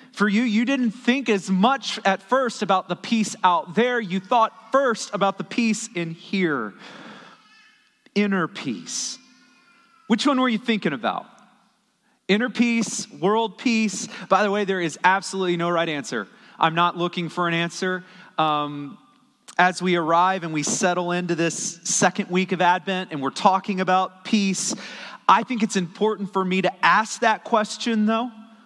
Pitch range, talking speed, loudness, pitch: 180-230 Hz, 165 wpm, -22 LUFS, 200 Hz